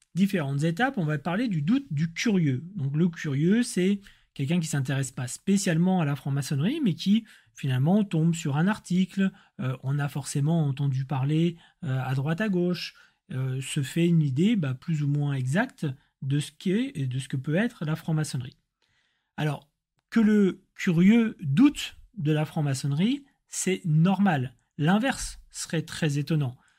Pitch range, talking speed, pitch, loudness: 145-190 Hz, 170 wpm, 160 Hz, -26 LUFS